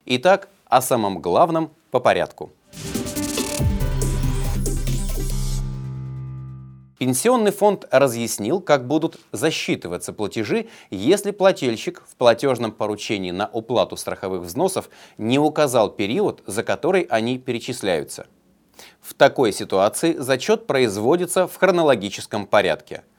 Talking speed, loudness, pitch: 95 wpm, -21 LUFS, 125 Hz